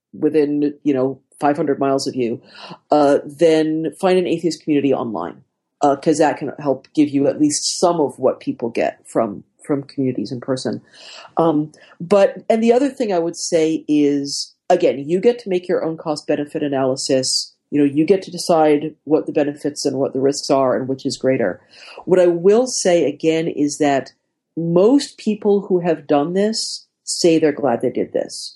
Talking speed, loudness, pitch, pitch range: 190 wpm, -18 LUFS, 155 Hz, 140-175 Hz